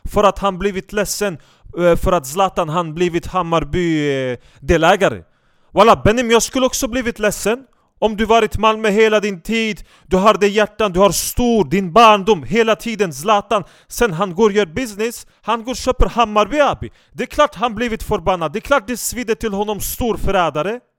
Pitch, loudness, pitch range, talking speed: 210 Hz, -16 LUFS, 190-230 Hz, 190 wpm